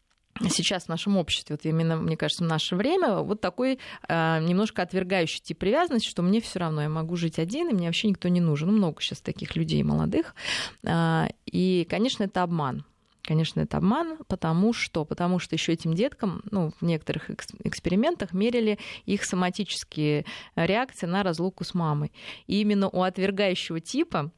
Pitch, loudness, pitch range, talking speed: 180 Hz, -27 LUFS, 160-205 Hz, 170 wpm